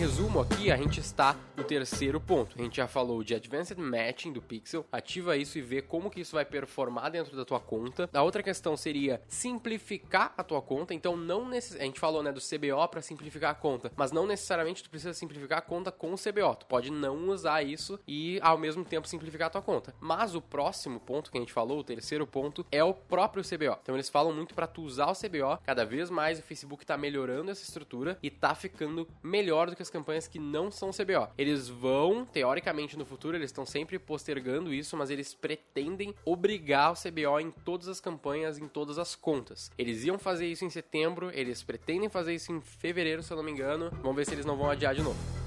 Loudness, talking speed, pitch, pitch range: -33 LUFS, 225 wpm, 155 Hz, 140-175 Hz